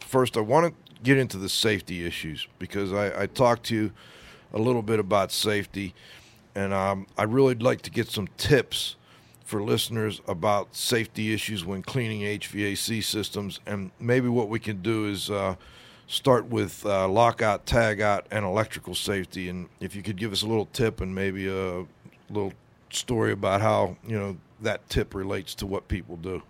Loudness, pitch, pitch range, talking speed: -27 LUFS, 105 Hz, 95-115 Hz, 180 wpm